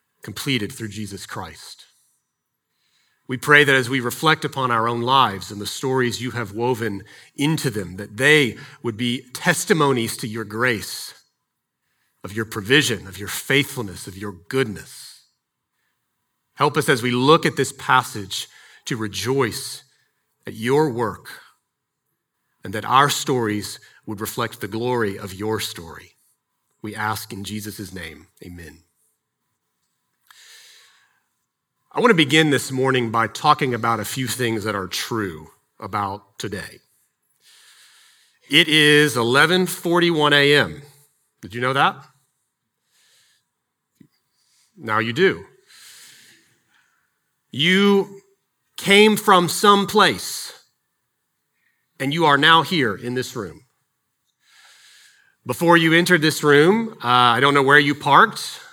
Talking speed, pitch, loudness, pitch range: 125 wpm, 130 Hz, -19 LUFS, 110-150 Hz